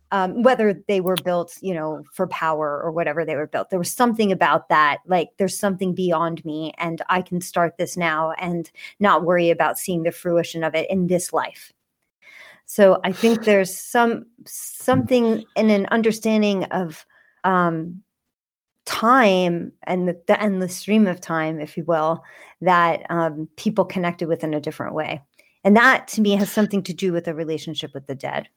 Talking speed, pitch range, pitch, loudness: 185 wpm, 165-200 Hz, 180 Hz, -21 LUFS